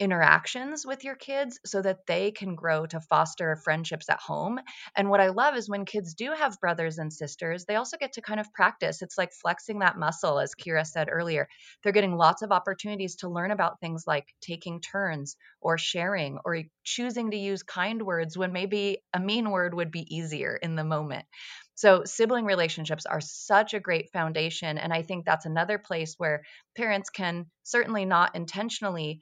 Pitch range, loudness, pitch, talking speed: 165-210 Hz, -28 LUFS, 180 Hz, 190 wpm